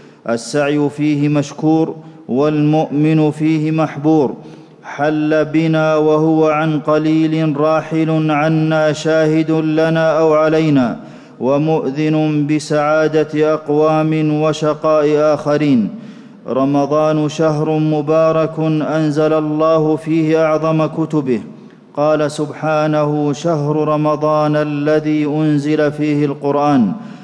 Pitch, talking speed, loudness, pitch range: 155 Hz, 85 wpm, -15 LUFS, 150-155 Hz